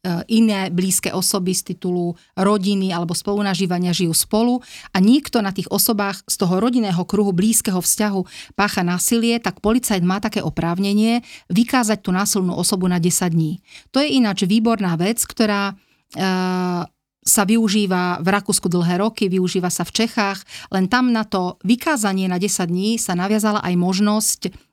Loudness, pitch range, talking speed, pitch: -19 LUFS, 185-215 Hz, 155 wpm, 195 Hz